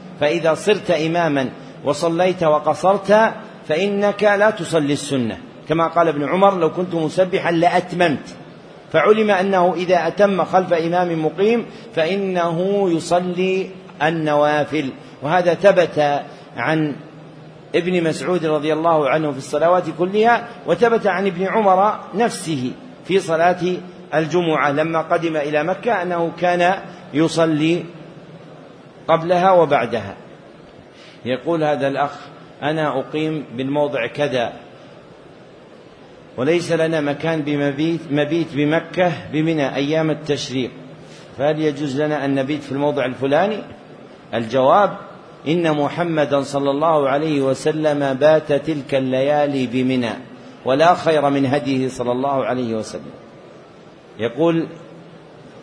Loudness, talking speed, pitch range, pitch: -18 LUFS, 105 wpm, 145-180 Hz, 160 Hz